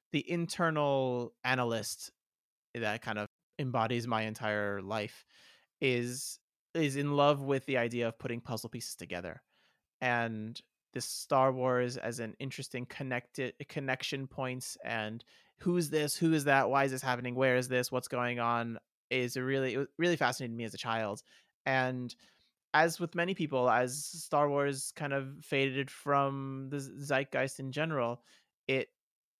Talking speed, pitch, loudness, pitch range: 155 wpm, 130 Hz, -33 LUFS, 120-140 Hz